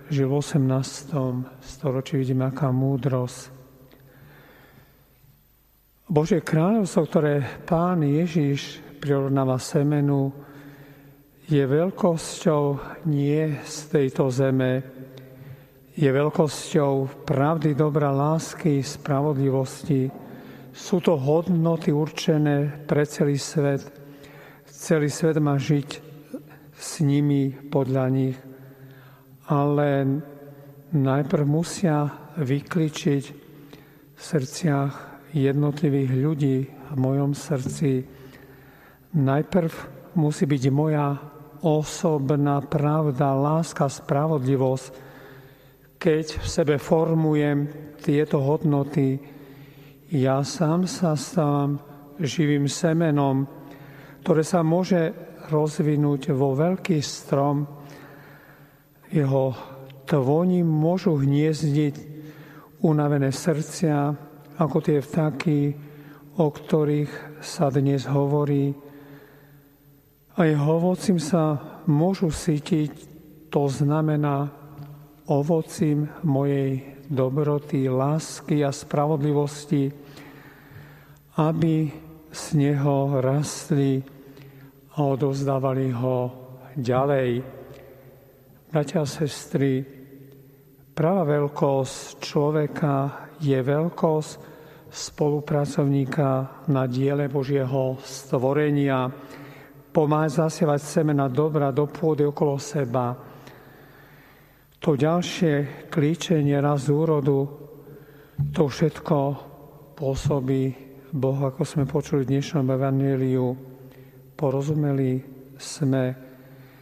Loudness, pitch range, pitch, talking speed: -24 LUFS, 135-155 Hz, 145 Hz, 80 wpm